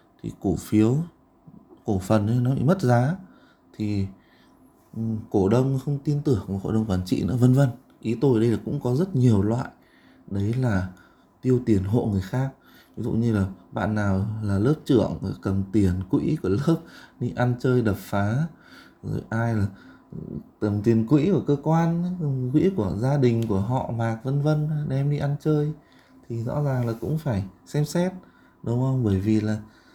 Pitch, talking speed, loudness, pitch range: 120 Hz, 190 wpm, -24 LUFS, 105-140 Hz